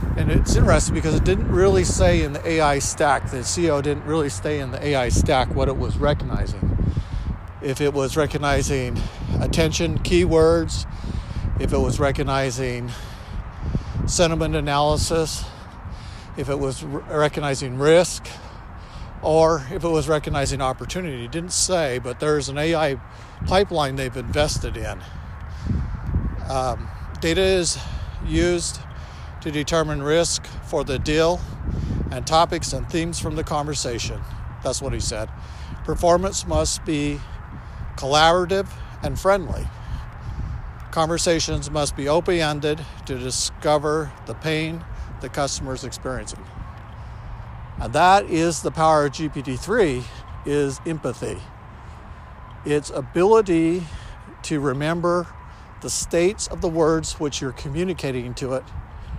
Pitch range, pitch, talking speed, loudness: 120-160 Hz, 145 Hz, 125 wpm, -22 LUFS